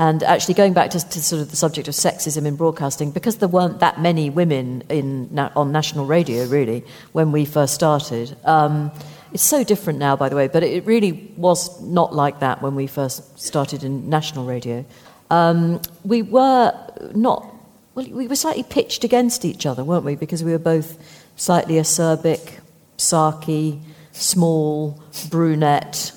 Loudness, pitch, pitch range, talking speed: -19 LUFS, 160 Hz, 145-175 Hz, 170 wpm